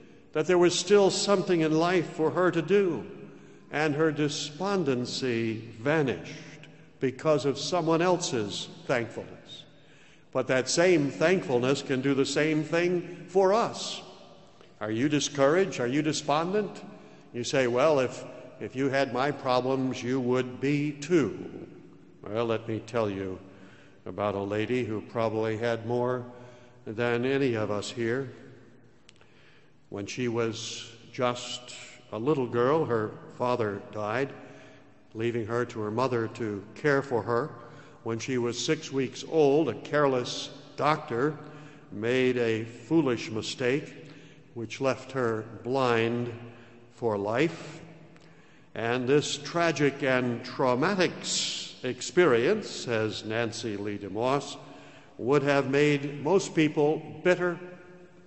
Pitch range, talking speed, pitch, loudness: 120-155 Hz, 125 wpm, 130 Hz, -28 LUFS